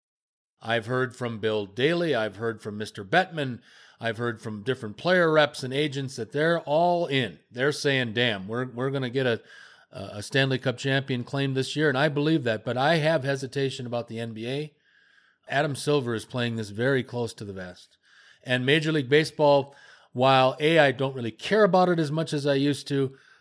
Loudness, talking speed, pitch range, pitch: -25 LUFS, 195 wpm, 120-150 Hz, 135 Hz